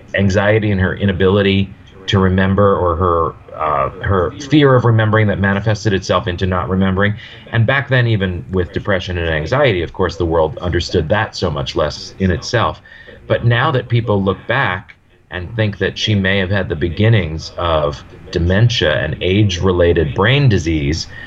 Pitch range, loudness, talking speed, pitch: 90-110 Hz, -15 LUFS, 170 wpm, 100 Hz